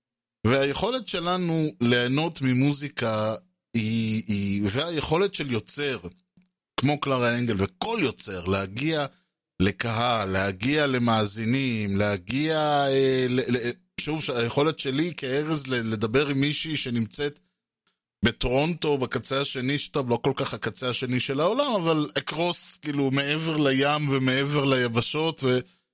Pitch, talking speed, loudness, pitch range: 135 Hz, 115 wpm, -25 LUFS, 120-150 Hz